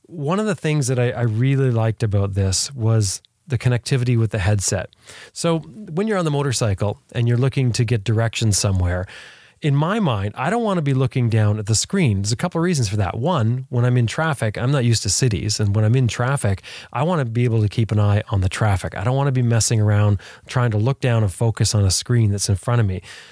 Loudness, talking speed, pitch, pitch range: -20 LUFS, 250 wpm, 120 Hz, 105-135 Hz